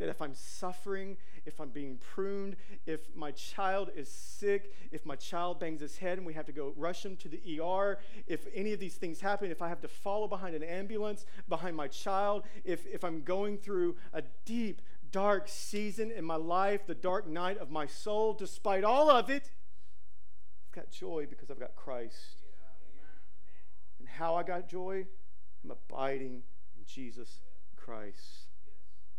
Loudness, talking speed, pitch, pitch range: -36 LUFS, 175 wpm, 170 Hz, 135-195 Hz